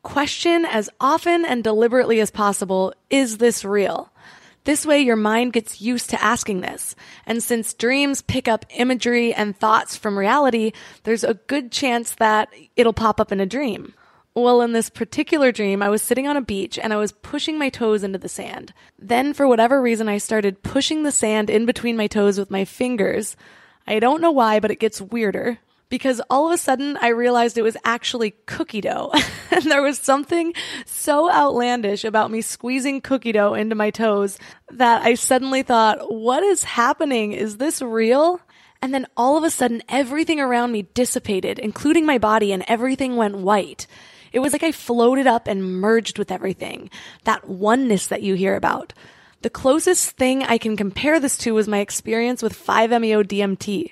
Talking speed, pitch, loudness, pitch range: 185 wpm, 235 Hz, -19 LUFS, 215-265 Hz